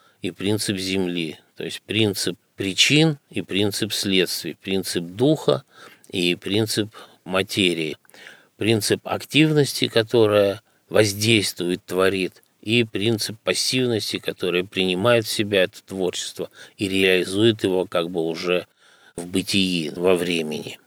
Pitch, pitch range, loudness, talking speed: 100 Hz, 90-110 Hz, -21 LUFS, 110 wpm